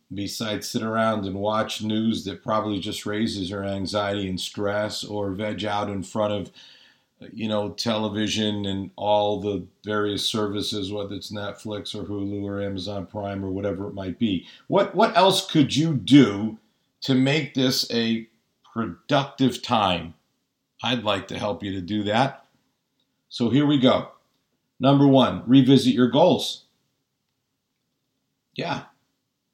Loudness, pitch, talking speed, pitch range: -23 LUFS, 105 Hz, 145 wpm, 100-125 Hz